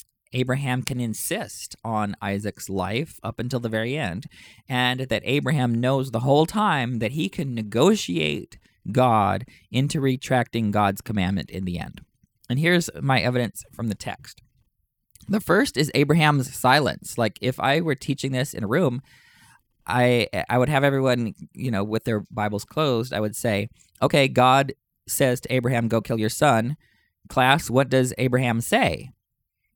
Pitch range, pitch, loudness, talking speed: 110-135 Hz, 125 Hz, -23 LUFS, 160 wpm